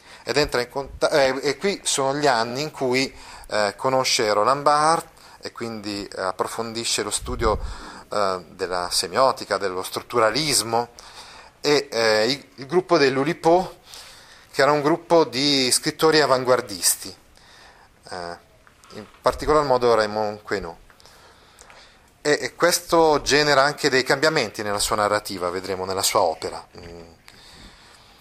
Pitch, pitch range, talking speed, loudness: 130 Hz, 105-150 Hz, 125 wpm, -21 LUFS